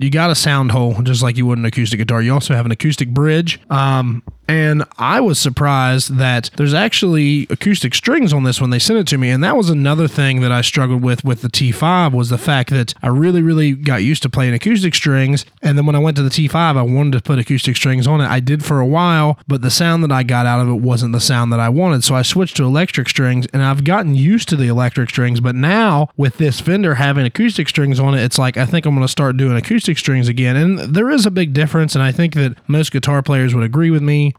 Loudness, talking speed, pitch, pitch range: -14 LUFS, 260 wpm, 140 Hz, 125-155 Hz